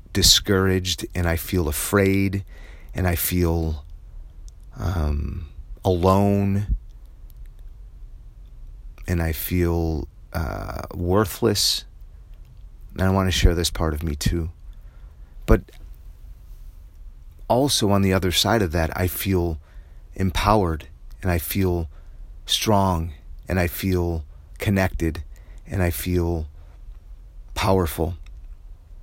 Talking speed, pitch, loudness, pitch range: 100 wpm, 90 Hz, -22 LUFS, 80-95 Hz